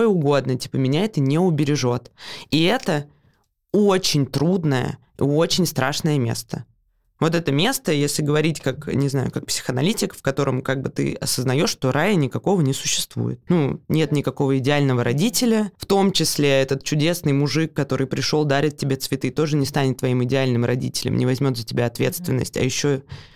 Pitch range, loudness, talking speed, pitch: 130-160 Hz, -21 LUFS, 160 wpm, 145 Hz